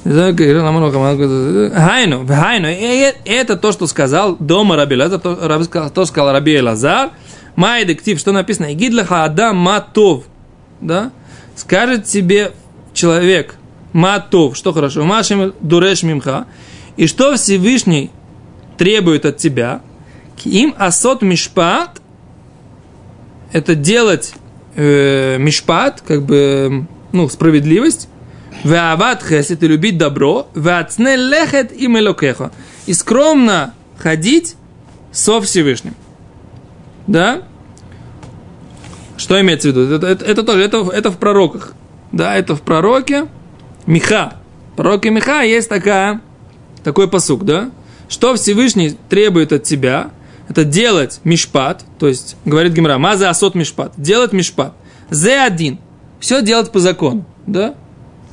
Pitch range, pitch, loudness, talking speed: 155-210 Hz, 180 Hz, -12 LUFS, 115 wpm